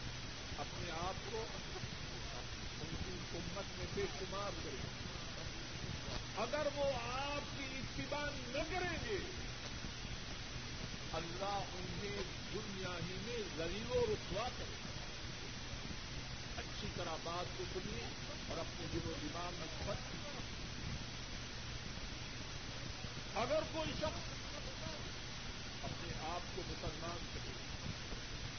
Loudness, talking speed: -44 LUFS, 95 wpm